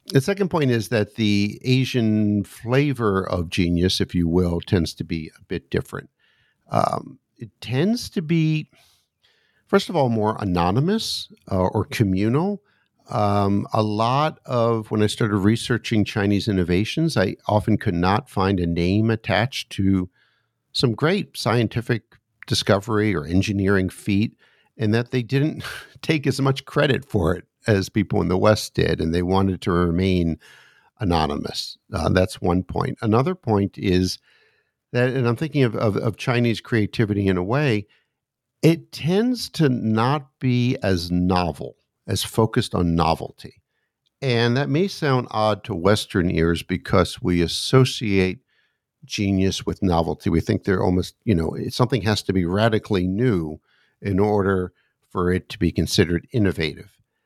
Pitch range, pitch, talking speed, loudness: 95-130 Hz, 110 Hz, 150 wpm, -22 LUFS